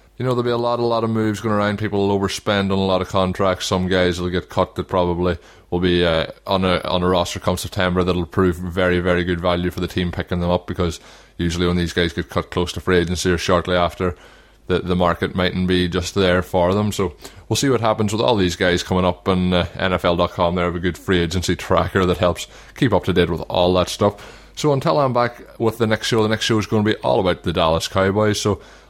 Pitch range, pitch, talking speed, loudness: 90-100 Hz, 90 Hz, 255 wpm, -19 LUFS